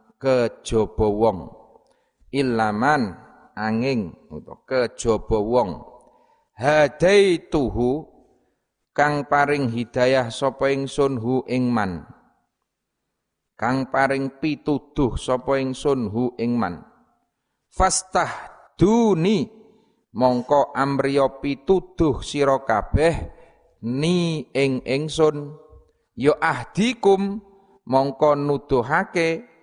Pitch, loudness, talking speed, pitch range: 140 Hz, -21 LUFS, 75 wpm, 130-165 Hz